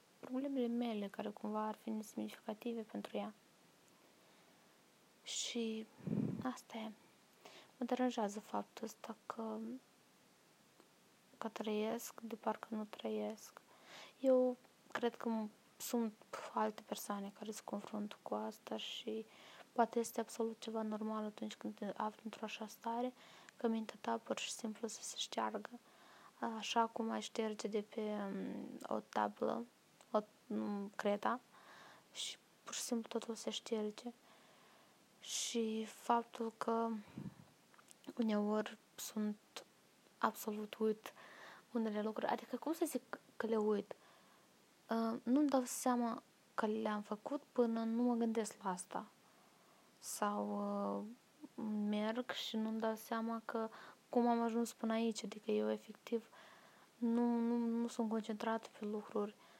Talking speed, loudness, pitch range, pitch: 125 wpm, -42 LUFS, 215-235 Hz, 225 Hz